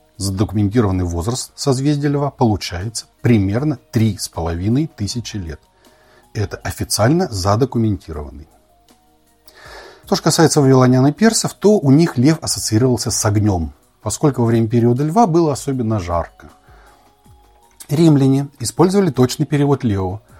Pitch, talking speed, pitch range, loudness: 120 Hz, 110 wpm, 105-145 Hz, -16 LUFS